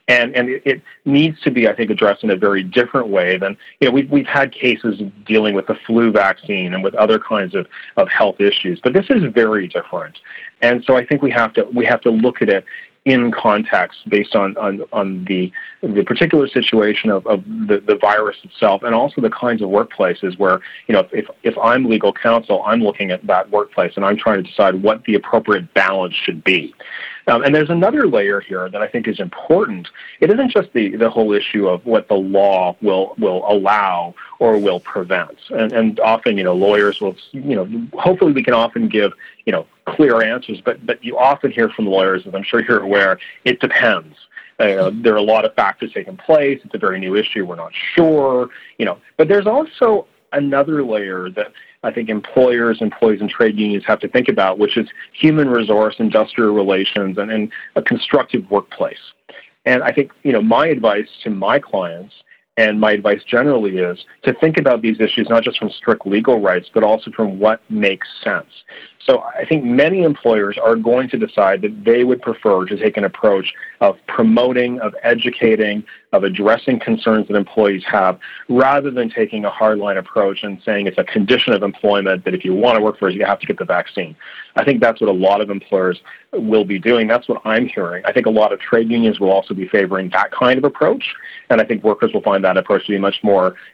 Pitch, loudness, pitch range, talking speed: 115 Hz, -16 LUFS, 100-130 Hz, 215 wpm